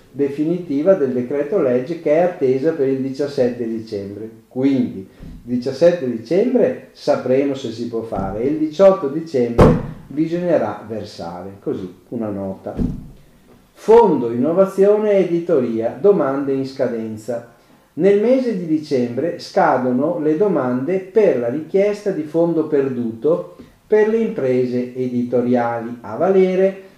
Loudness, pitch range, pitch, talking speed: -18 LUFS, 120-175 Hz, 135 Hz, 120 wpm